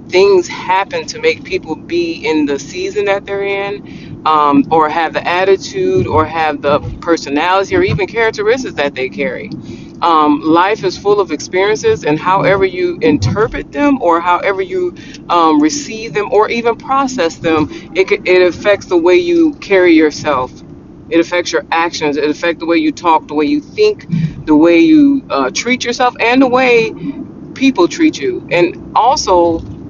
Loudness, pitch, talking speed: -12 LUFS, 195 Hz, 170 wpm